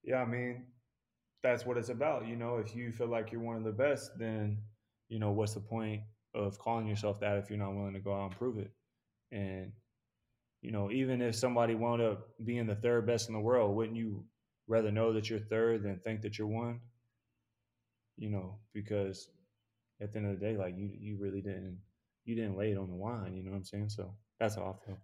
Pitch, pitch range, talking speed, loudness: 110 Hz, 100-115 Hz, 230 wpm, -37 LUFS